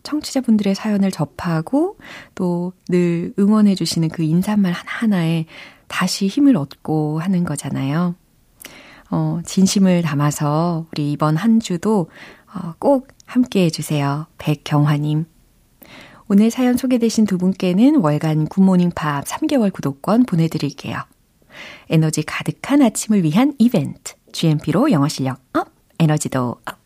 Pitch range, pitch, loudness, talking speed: 155-210 Hz, 175 Hz, -18 LUFS, 275 characters per minute